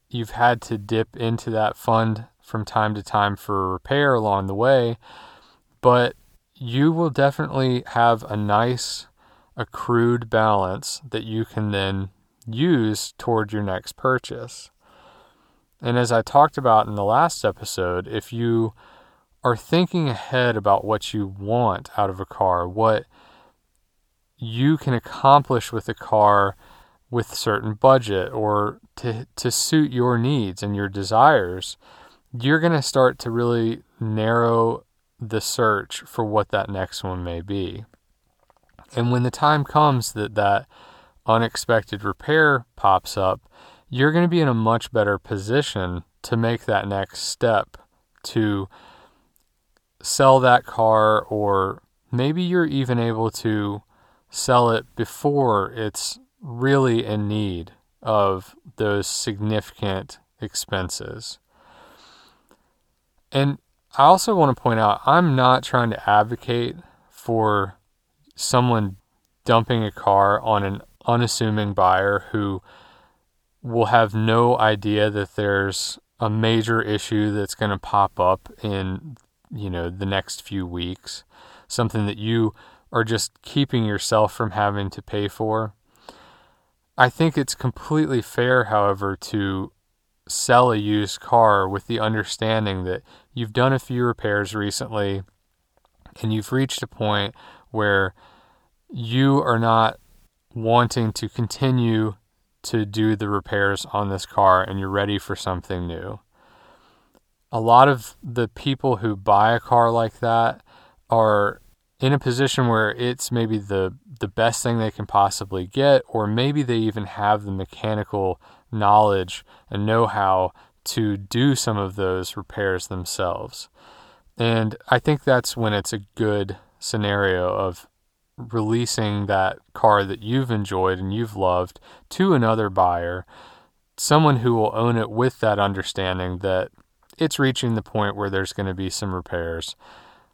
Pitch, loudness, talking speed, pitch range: 110 Hz, -21 LUFS, 140 wpm, 100-120 Hz